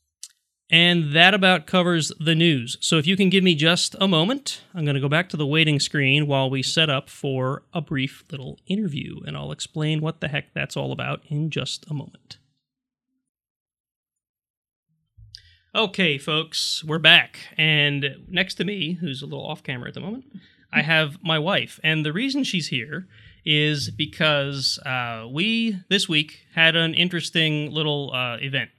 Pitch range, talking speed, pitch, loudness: 140-175 Hz, 175 wpm, 155 Hz, -21 LUFS